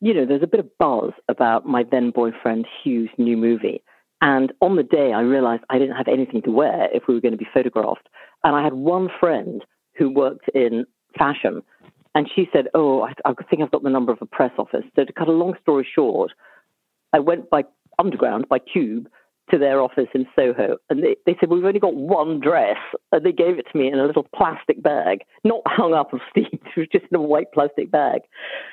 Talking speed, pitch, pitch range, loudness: 225 wpm, 145 Hz, 130-180 Hz, -20 LUFS